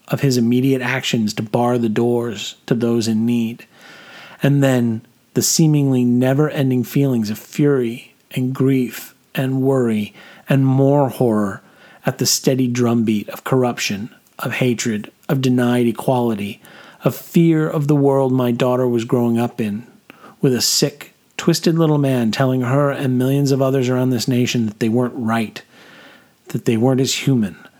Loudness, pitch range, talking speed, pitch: -18 LUFS, 120-135 Hz, 160 wpm, 125 Hz